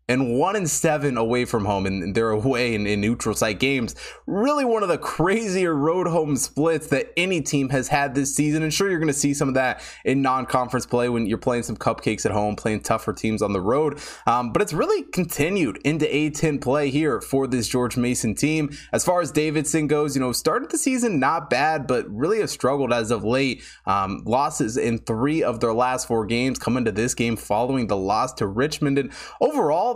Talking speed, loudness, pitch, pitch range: 215 wpm, -22 LUFS, 135 Hz, 115-155 Hz